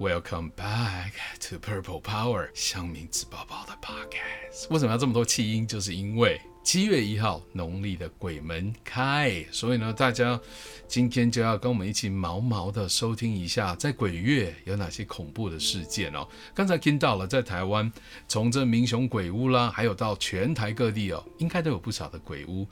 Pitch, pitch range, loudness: 110 Hz, 95-125 Hz, -28 LUFS